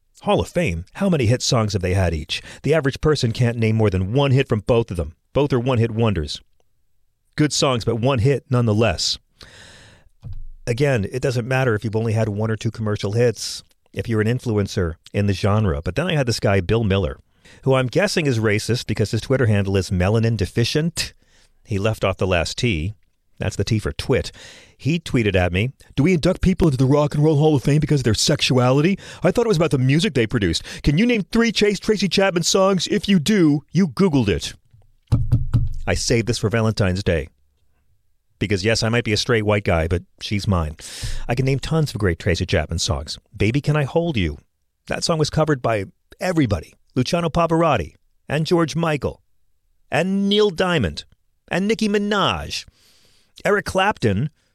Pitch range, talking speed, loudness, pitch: 100-150 Hz, 200 wpm, -20 LUFS, 115 Hz